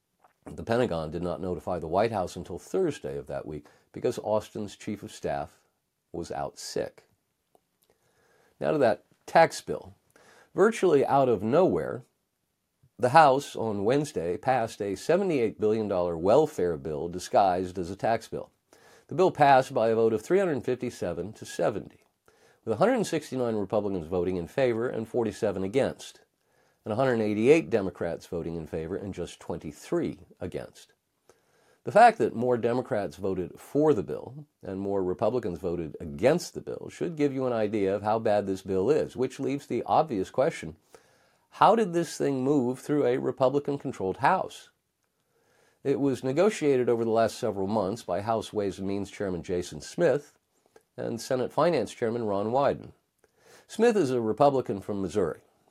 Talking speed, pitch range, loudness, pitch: 155 wpm, 95-135 Hz, -27 LUFS, 110 Hz